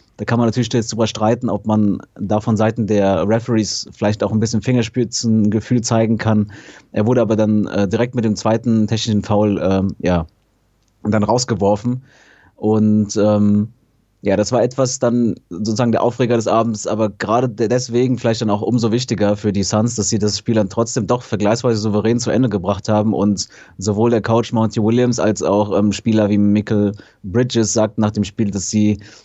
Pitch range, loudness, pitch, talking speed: 105-115 Hz, -17 LUFS, 110 Hz, 185 wpm